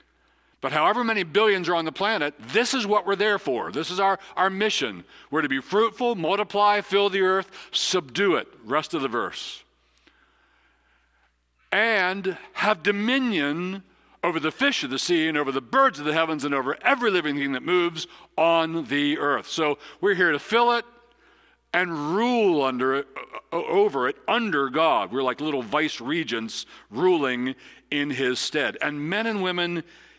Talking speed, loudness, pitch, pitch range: 170 wpm, -24 LUFS, 175 Hz, 145-205 Hz